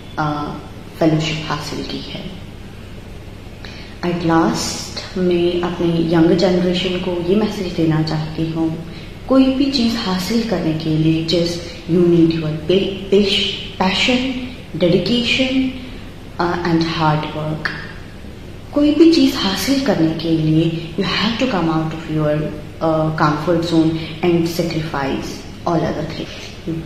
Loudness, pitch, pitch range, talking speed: -17 LUFS, 165 Hz, 155-185 Hz, 120 wpm